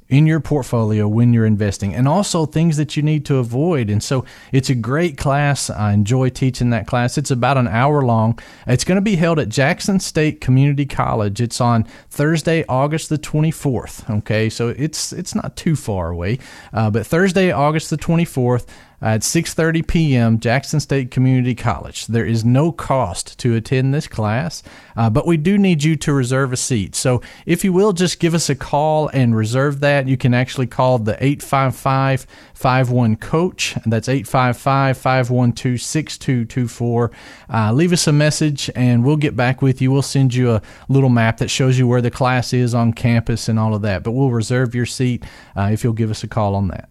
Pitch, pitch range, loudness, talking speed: 130 Hz, 115-150 Hz, -17 LUFS, 190 wpm